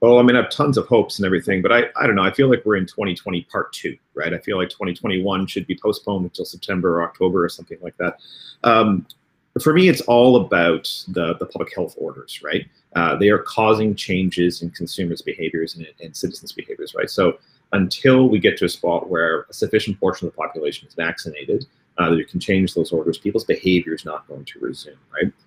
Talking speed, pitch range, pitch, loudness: 225 wpm, 90-120 Hz, 100 Hz, -19 LUFS